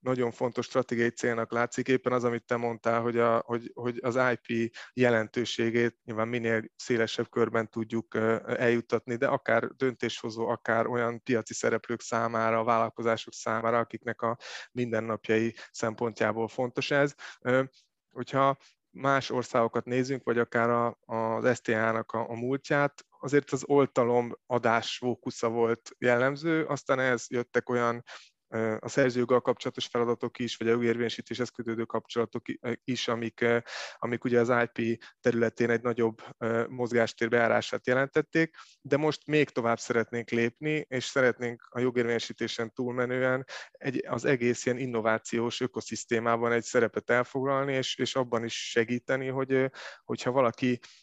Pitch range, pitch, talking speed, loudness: 115-125 Hz, 120 Hz, 130 wpm, -29 LUFS